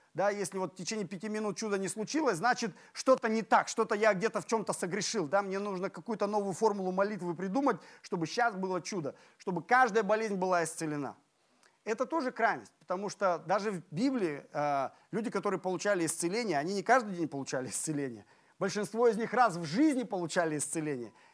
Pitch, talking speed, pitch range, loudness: 200 Hz, 175 wpm, 175-225 Hz, -32 LUFS